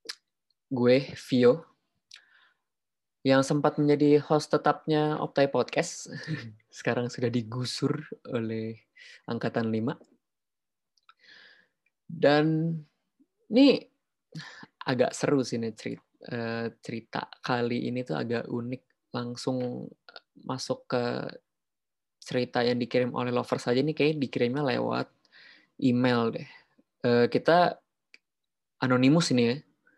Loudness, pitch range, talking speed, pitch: -27 LUFS, 120-150 Hz, 95 wpm, 125 Hz